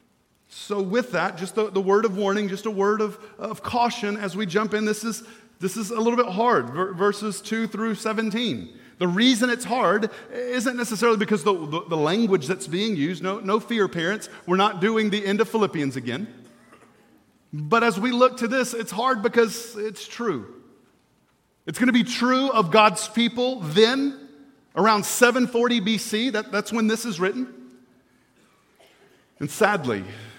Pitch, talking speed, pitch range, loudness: 215 Hz, 175 wpm, 195-235 Hz, -23 LUFS